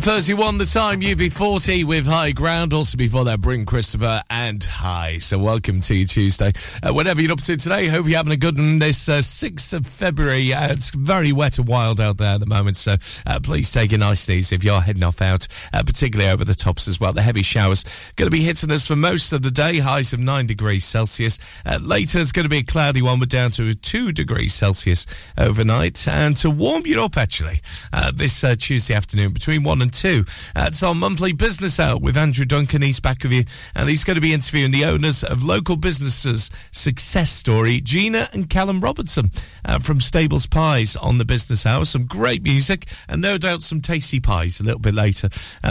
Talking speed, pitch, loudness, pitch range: 220 wpm, 125 Hz, -19 LUFS, 105-155 Hz